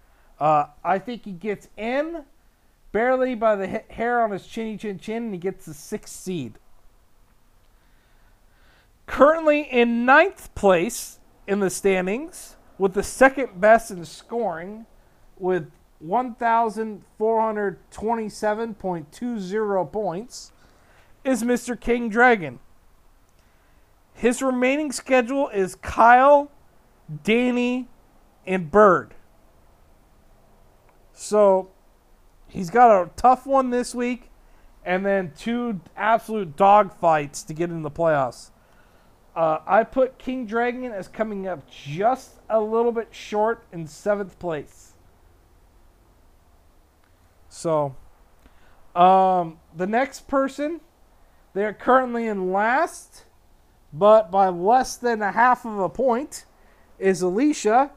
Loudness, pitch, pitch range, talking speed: -22 LUFS, 200 Hz, 155-240 Hz, 110 wpm